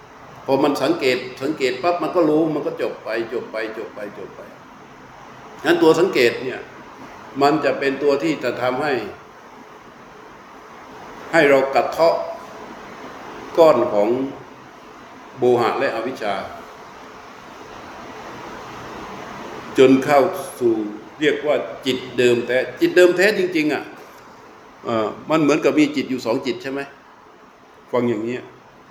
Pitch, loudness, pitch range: 135 Hz, -19 LUFS, 125-170 Hz